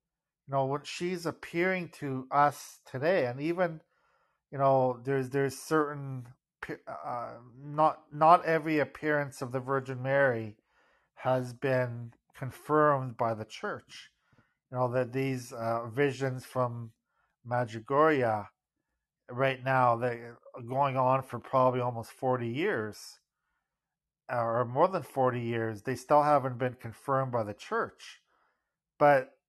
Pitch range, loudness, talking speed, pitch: 125-145 Hz, -30 LUFS, 130 wpm, 135 Hz